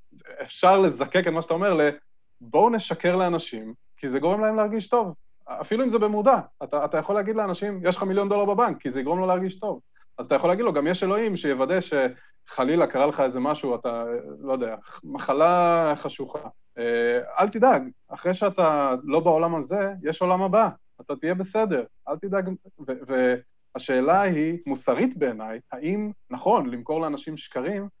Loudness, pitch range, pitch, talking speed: -24 LUFS, 140-200 Hz, 175 Hz, 170 wpm